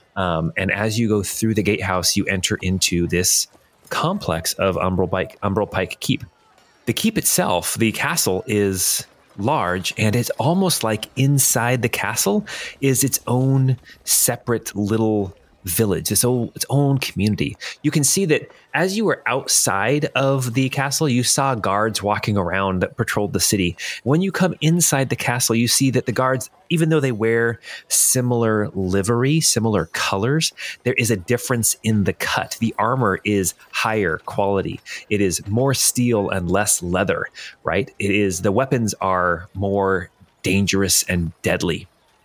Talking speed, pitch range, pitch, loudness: 160 wpm, 95-130 Hz, 110 Hz, -19 LUFS